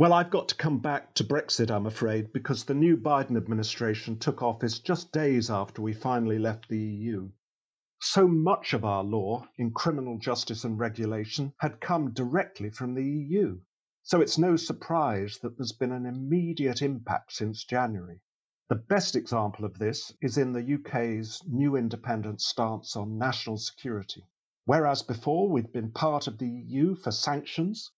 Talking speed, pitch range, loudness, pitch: 165 wpm, 110-145 Hz, -29 LUFS, 125 Hz